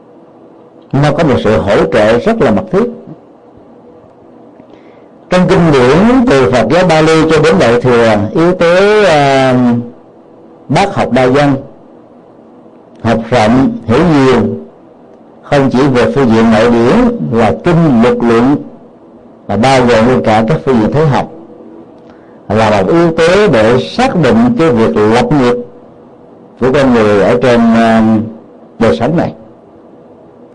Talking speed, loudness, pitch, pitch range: 140 wpm, -9 LUFS, 120 Hz, 110-160 Hz